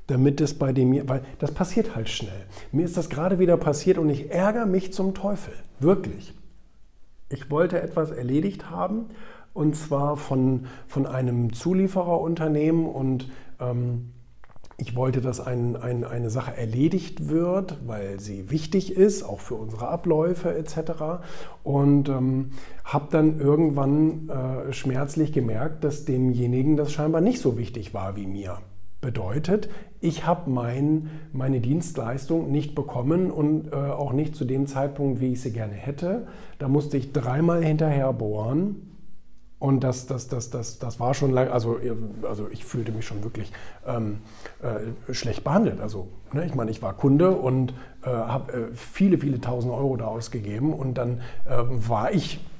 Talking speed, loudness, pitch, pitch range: 160 wpm, -25 LUFS, 135 Hz, 120-160 Hz